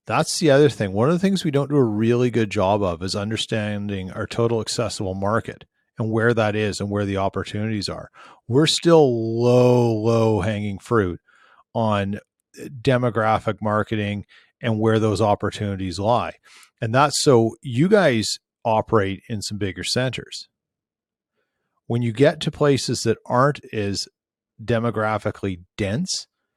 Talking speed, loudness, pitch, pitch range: 145 wpm, -21 LUFS, 110 Hz, 105-125 Hz